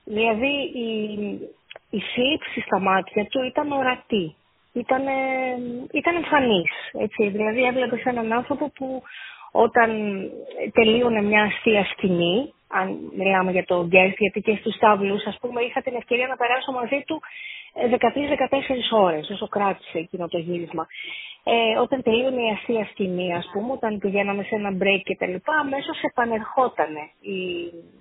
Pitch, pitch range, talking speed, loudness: 230 Hz, 200-260 Hz, 140 wpm, -23 LUFS